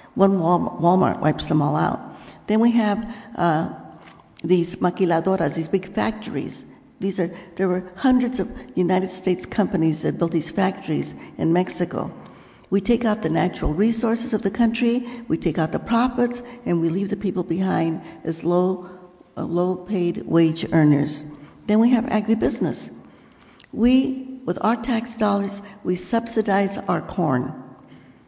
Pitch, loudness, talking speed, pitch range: 190 Hz, -22 LUFS, 150 wpm, 175-225 Hz